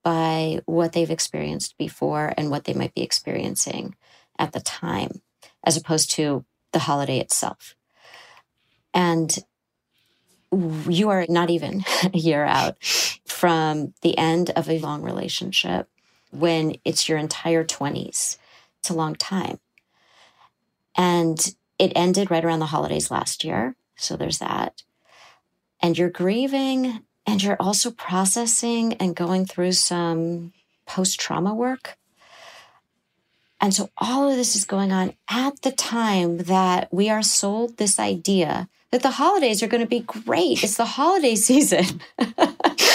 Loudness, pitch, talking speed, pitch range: -22 LUFS, 180 Hz, 140 wpm, 165-215 Hz